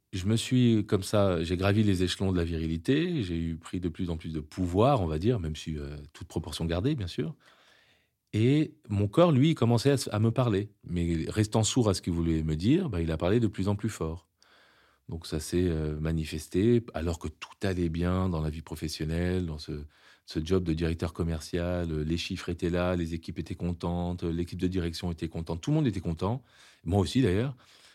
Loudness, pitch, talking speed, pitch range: -29 LUFS, 90 Hz, 215 wpm, 85-105 Hz